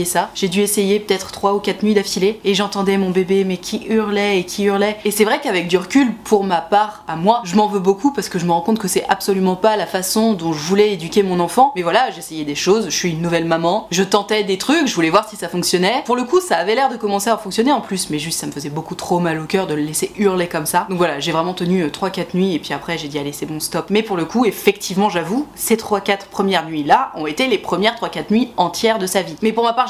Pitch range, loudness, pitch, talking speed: 175-210 Hz, -17 LUFS, 195 Hz, 285 wpm